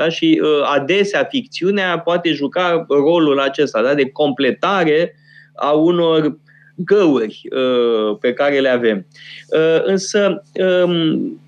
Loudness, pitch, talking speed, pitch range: -16 LUFS, 160 Hz, 100 wpm, 140-180 Hz